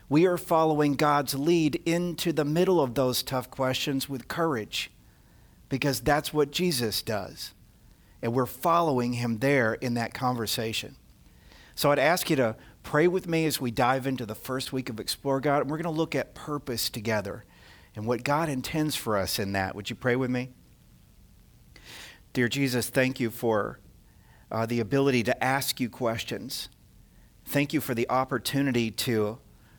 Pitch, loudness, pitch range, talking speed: 130 Hz, -27 LUFS, 115-145 Hz, 170 wpm